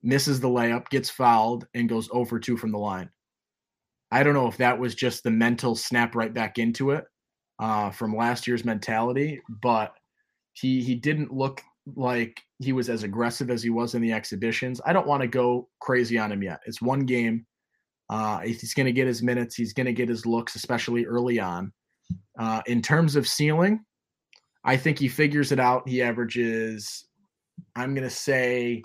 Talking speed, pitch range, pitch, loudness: 195 wpm, 115-130 Hz, 120 Hz, -25 LUFS